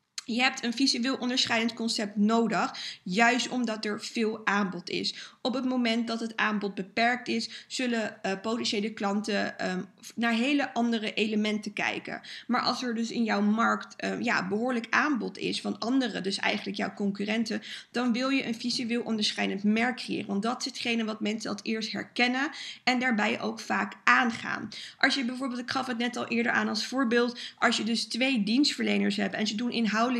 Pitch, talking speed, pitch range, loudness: 230 Hz, 185 wpm, 215-245 Hz, -28 LUFS